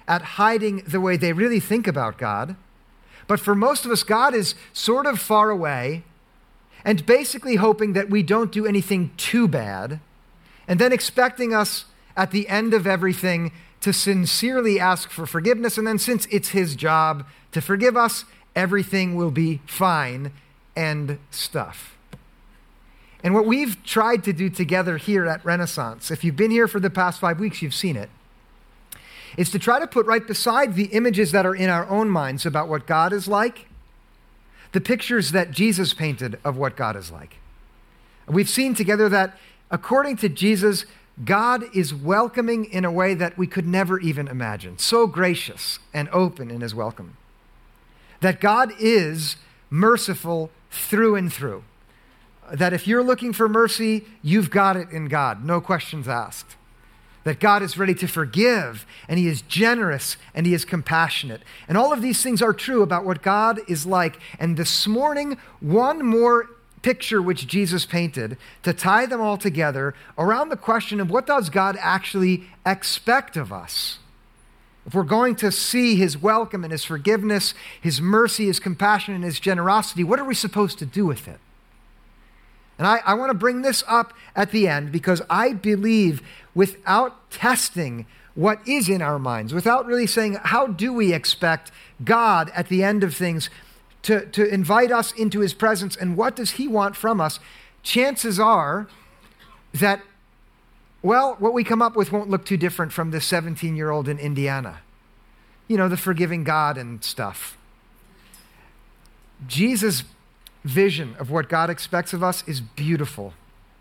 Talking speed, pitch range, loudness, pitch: 170 wpm, 160-220 Hz, -21 LUFS, 190 Hz